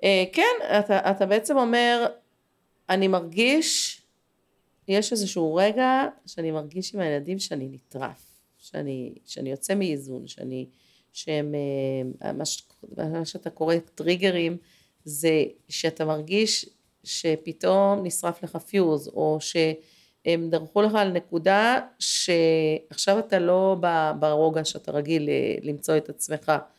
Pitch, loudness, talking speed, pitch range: 170 Hz, -24 LUFS, 110 wpm, 155-195 Hz